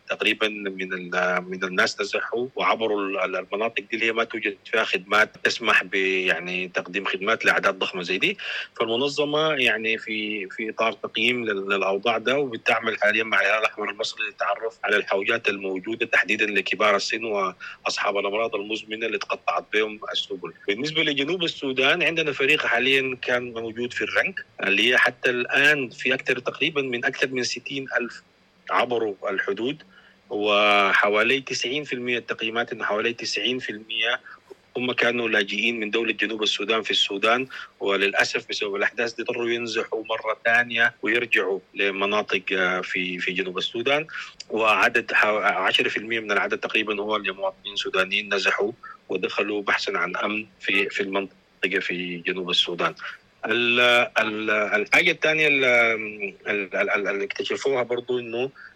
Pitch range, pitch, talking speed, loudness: 105-125 Hz, 115 Hz, 130 wpm, -23 LUFS